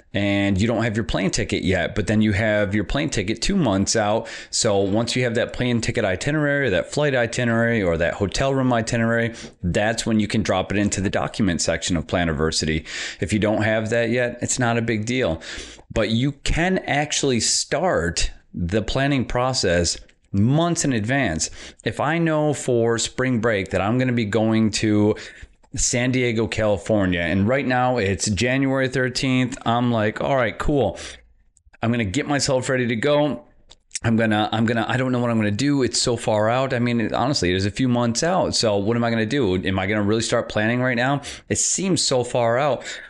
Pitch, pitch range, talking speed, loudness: 115 Hz, 105-125 Hz, 215 wpm, -21 LUFS